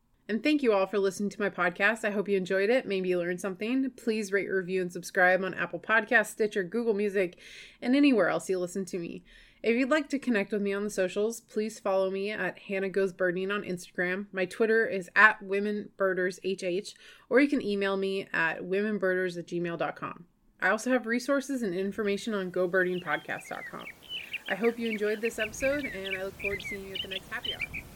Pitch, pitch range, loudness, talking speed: 200 Hz, 185-220 Hz, -29 LUFS, 205 wpm